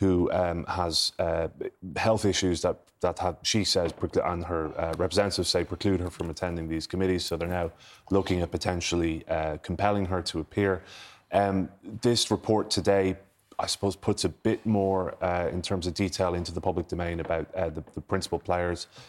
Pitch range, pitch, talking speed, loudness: 85-100 Hz, 90 Hz, 180 wpm, -28 LUFS